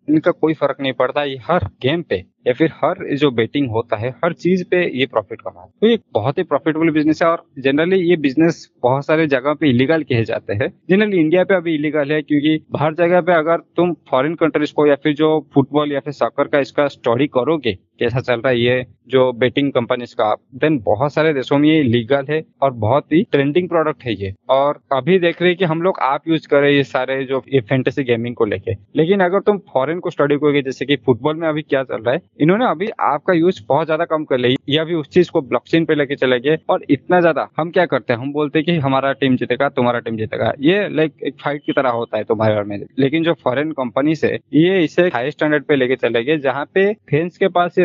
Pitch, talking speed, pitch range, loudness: 145 Hz, 240 wpm, 130-160 Hz, -17 LUFS